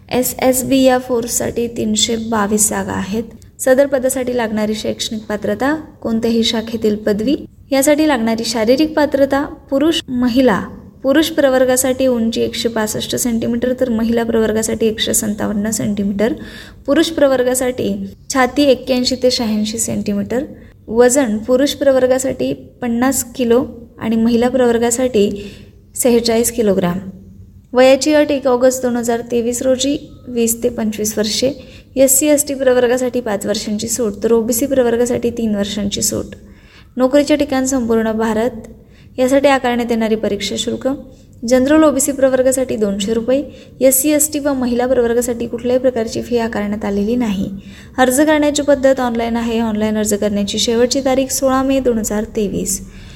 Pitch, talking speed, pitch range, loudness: 245 Hz, 135 wpm, 225-260 Hz, -15 LUFS